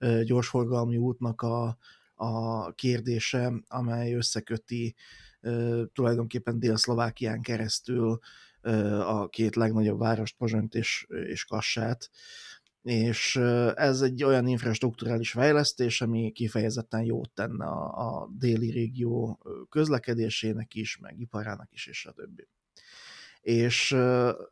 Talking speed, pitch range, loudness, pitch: 100 wpm, 115-120 Hz, -29 LUFS, 115 Hz